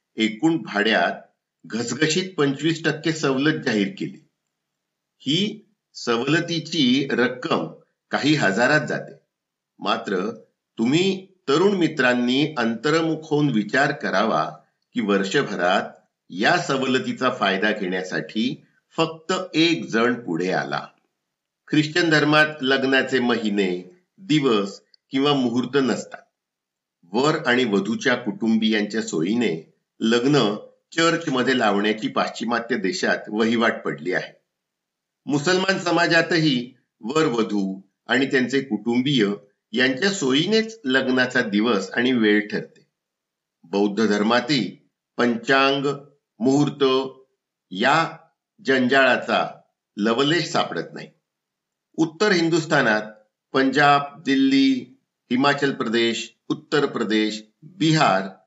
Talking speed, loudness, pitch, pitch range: 90 wpm, -21 LUFS, 135 Hz, 115-155 Hz